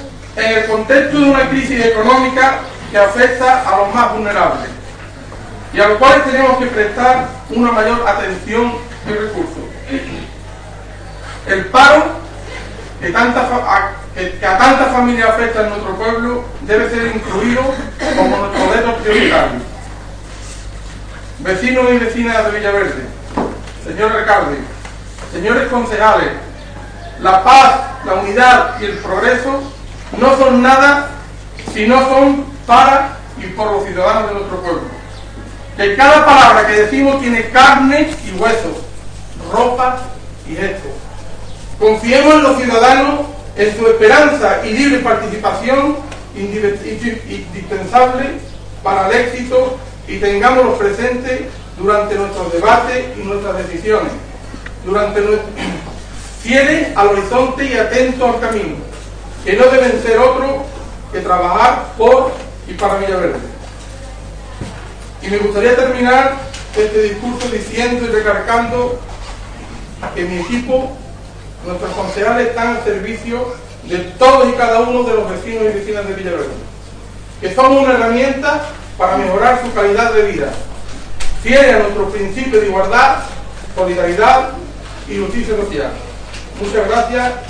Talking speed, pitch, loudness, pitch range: 125 wpm, 215 Hz, -12 LUFS, 185-250 Hz